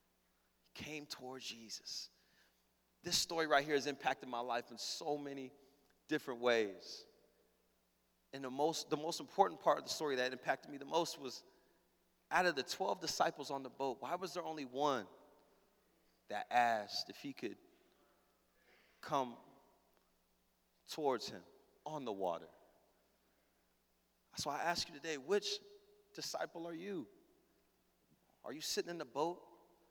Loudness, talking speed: -40 LUFS, 140 wpm